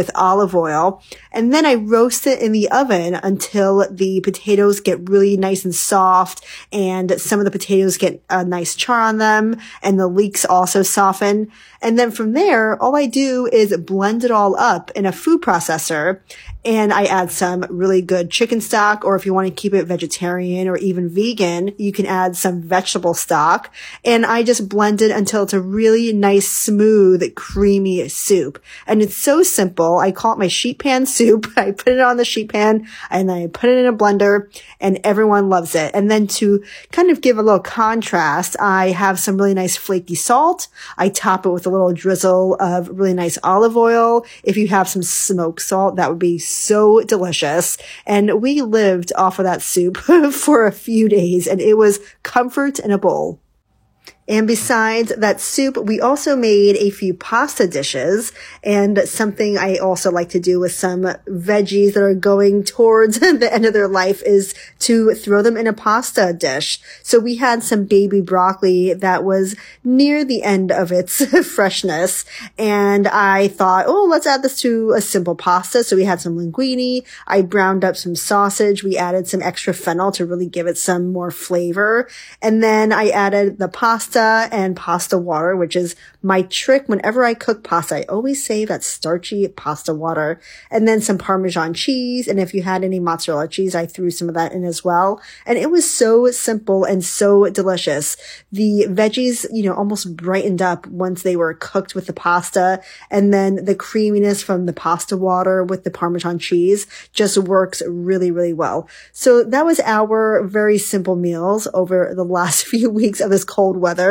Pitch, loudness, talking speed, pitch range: 195 Hz, -16 LUFS, 190 wpm, 185-220 Hz